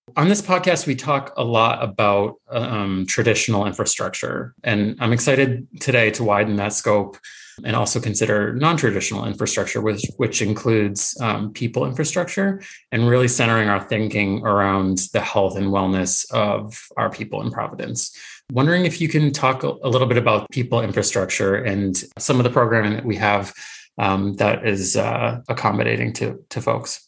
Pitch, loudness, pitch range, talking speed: 115 Hz, -19 LUFS, 100-125 Hz, 165 wpm